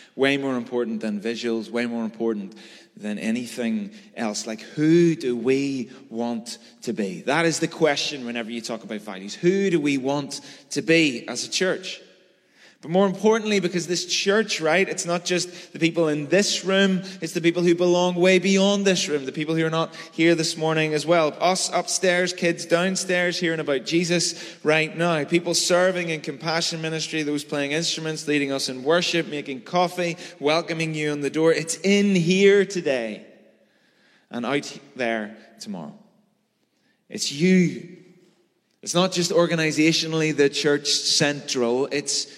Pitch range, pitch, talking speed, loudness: 145-180 Hz, 165 Hz, 165 wpm, -22 LUFS